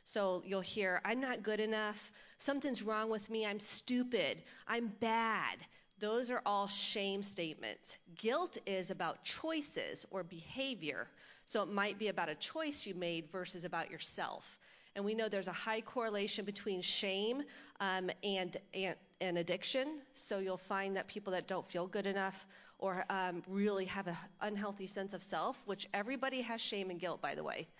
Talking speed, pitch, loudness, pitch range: 175 wpm, 200 Hz, -39 LUFS, 185-225 Hz